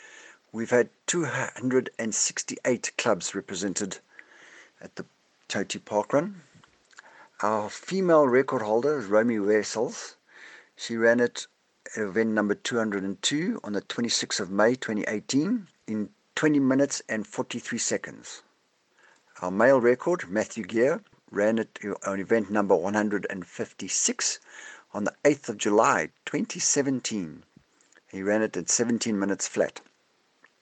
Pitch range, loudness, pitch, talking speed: 105-140 Hz, -26 LUFS, 115 Hz, 120 wpm